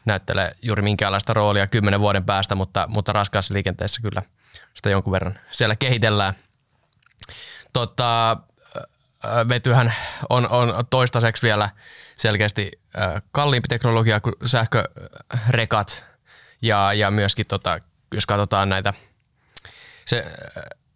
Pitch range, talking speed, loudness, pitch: 100-120 Hz, 105 wpm, -21 LUFS, 105 Hz